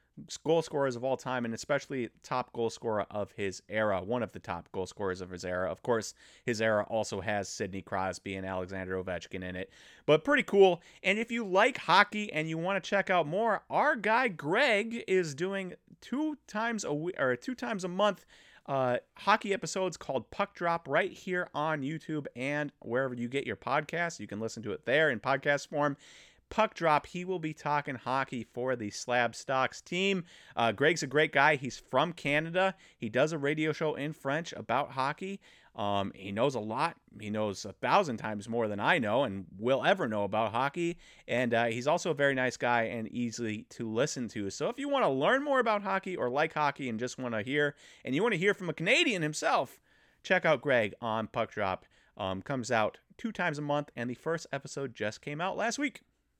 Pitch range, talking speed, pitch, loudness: 115-180 Hz, 210 wpm, 140 Hz, -31 LUFS